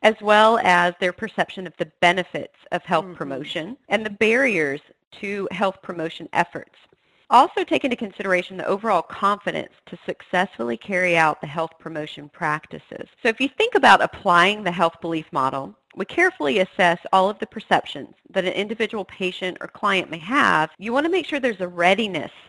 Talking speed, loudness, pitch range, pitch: 175 wpm, -21 LUFS, 170-220 Hz, 185 Hz